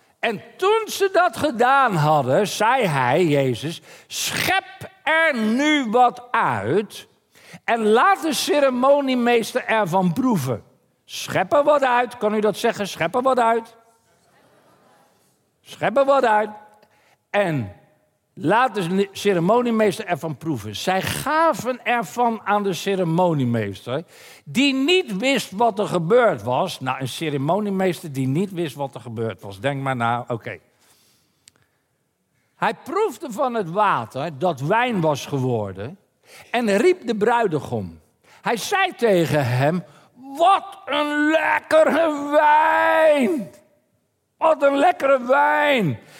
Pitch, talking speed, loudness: 215 Hz, 125 wpm, -20 LUFS